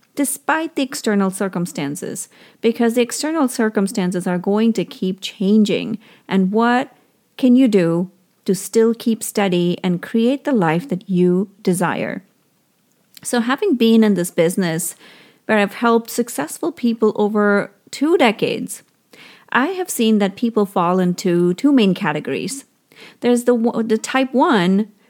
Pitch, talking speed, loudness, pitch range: 215 Hz, 140 wpm, -18 LUFS, 185-240 Hz